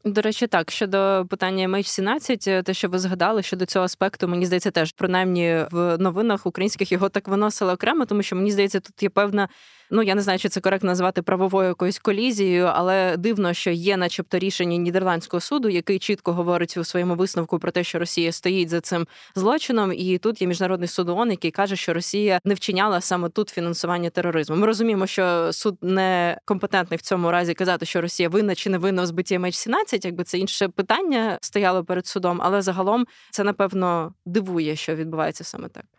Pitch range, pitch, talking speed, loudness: 175-200 Hz, 185 Hz, 190 wpm, -22 LUFS